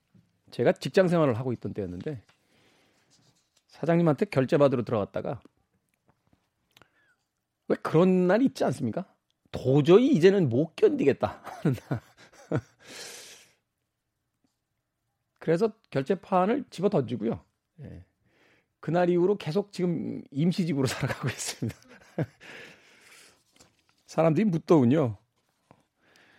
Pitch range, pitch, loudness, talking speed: 125-185 Hz, 155 Hz, -26 LUFS, 225 characters per minute